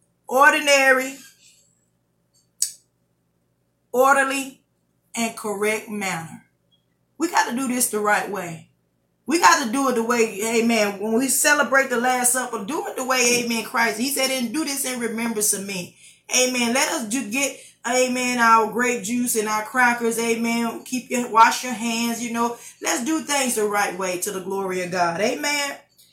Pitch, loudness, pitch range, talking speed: 230 Hz, -21 LUFS, 205-255 Hz, 170 wpm